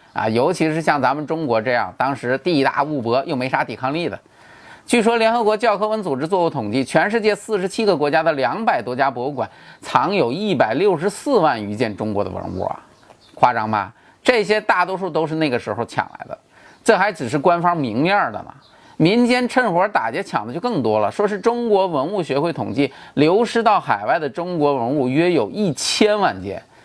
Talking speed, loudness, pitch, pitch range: 305 characters per minute, -19 LUFS, 170 Hz, 135-210 Hz